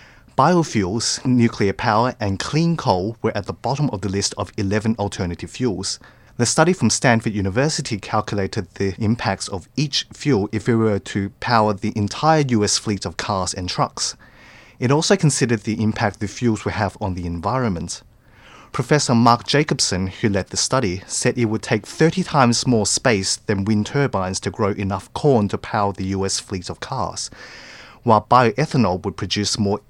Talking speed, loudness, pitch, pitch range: 175 wpm, -20 LUFS, 110 Hz, 100-125 Hz